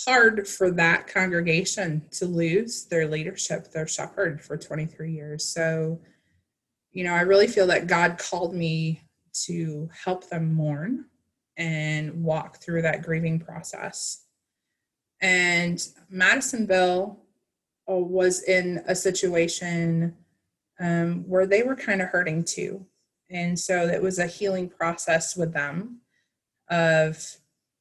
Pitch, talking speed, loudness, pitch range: 175 Hz, 125 wpm, -25 LUFS, 160-185 Hz